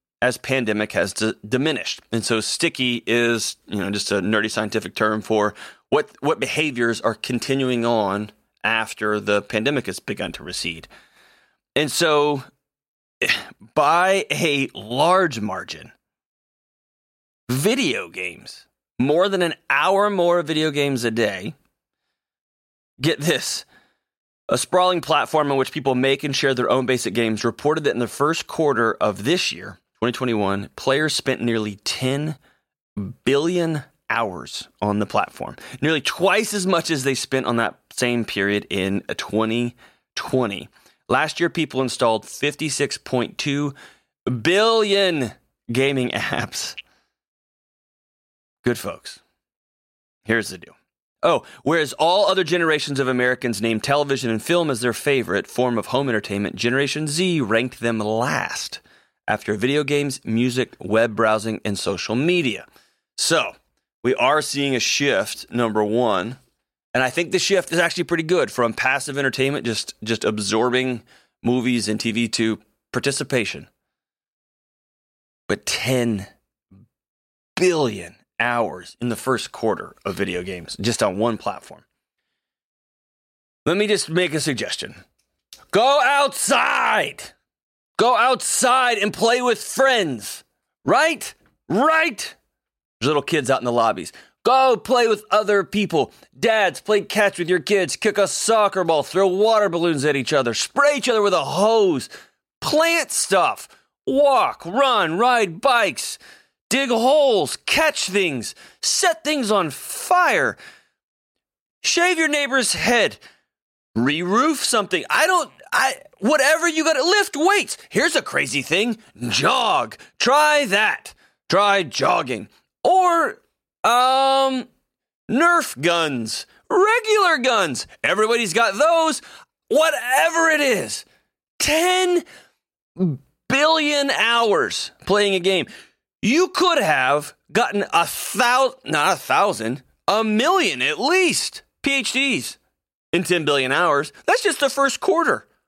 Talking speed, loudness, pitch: 130 wpm, -20 LUFS, 150 Hz